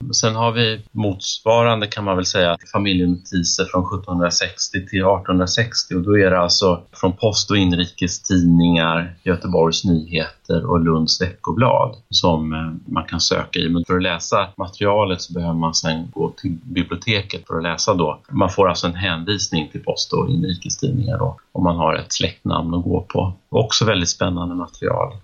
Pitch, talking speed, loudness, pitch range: 90 Hz, 165 wpm, -19 LUFS, 85-100 Hz